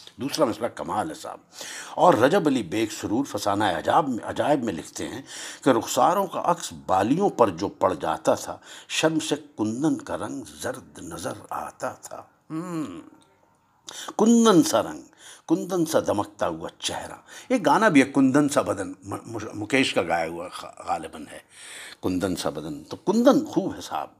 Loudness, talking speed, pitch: -24 LUFS, 160 wpm, 230 Hz